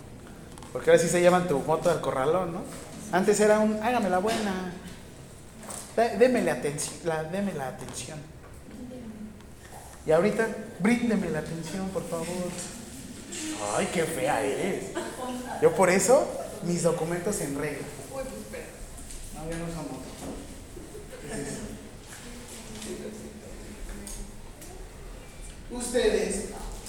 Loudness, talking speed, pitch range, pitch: -27 LUFS, 110 wpm, 150-225 Hz, 180 Hz